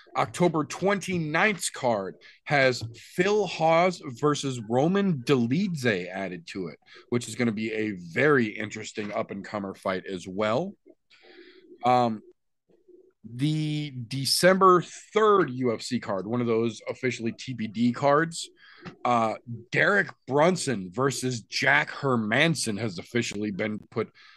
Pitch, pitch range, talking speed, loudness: 130 Hz, 115-175 Hz, 120 wpm, -26 LUFS